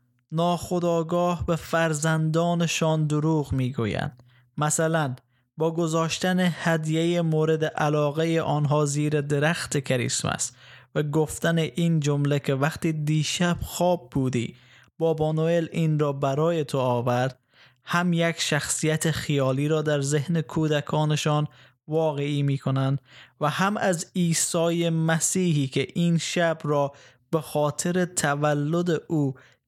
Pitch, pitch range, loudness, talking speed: 155 Hz, 140-165 Hz, -25 LUFS, 115 wpm